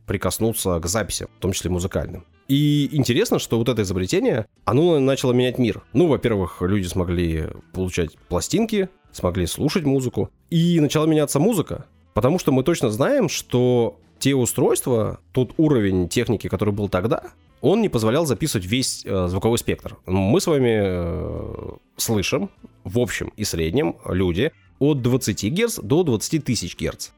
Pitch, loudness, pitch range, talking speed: 110 Hz, -21 LUFS, 95-130 Hz, 150 wpm